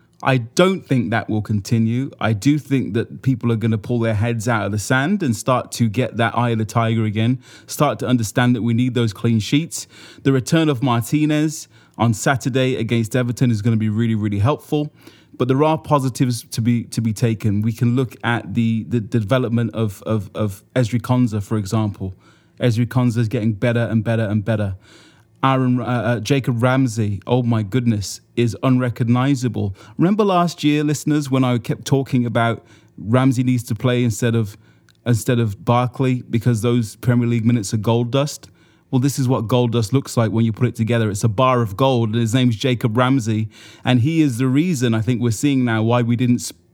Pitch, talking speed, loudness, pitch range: 120 Hz, 205 wpm, -19 LUFS, 115-130 Hz